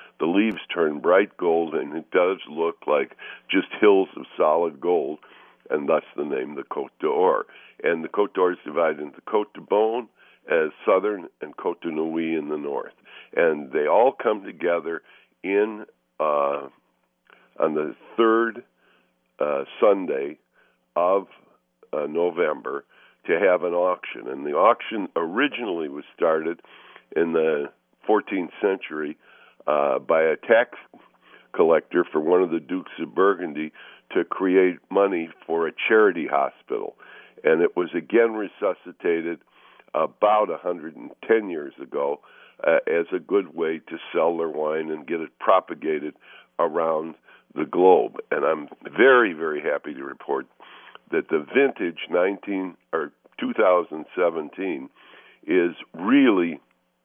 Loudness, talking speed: -23 LUFS, 145 wpm